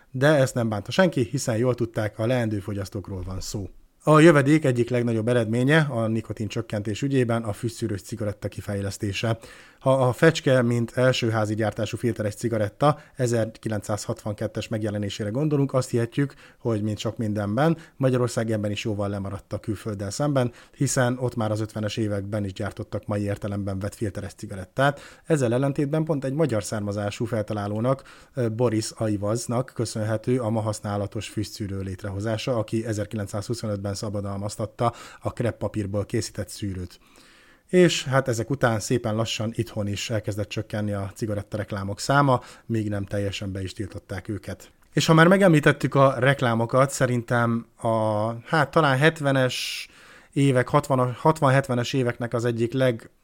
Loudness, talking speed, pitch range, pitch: -24 LUFS, 140 wpm, 105-130 Hz, 115 Hz